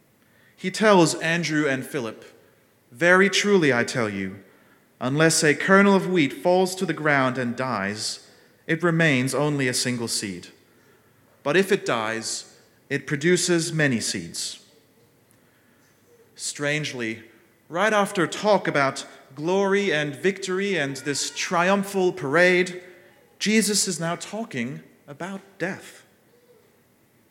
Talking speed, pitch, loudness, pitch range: 115 wpm, 155 Hz, -22 LUFS, 130-185 Hz